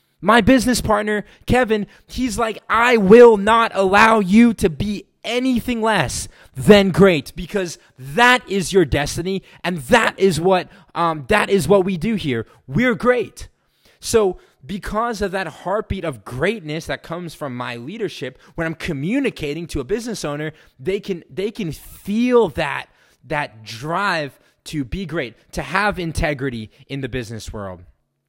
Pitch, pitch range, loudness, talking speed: 185 Hz, 145-215 Hz, -18 LUFS, 155 wpm